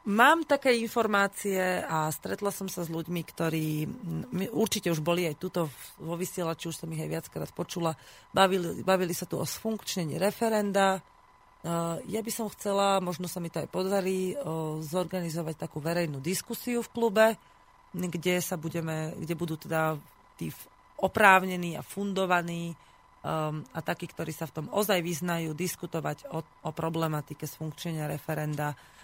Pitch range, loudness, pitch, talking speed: 160-195 Hz, -30 LUFS, 175 Hz, 140 wpm